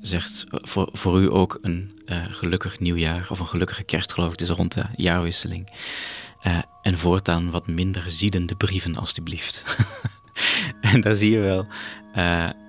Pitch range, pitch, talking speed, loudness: 85-105 Hz, 95 Hz, 165 wpm, -23 LUFS